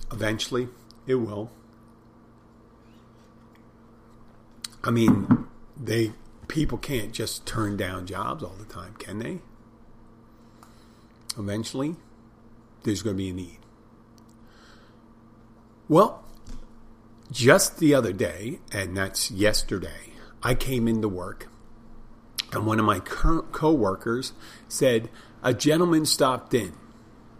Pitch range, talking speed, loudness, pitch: 110-115 Hz, 105 wpm, -25 LUFS, 115 Hz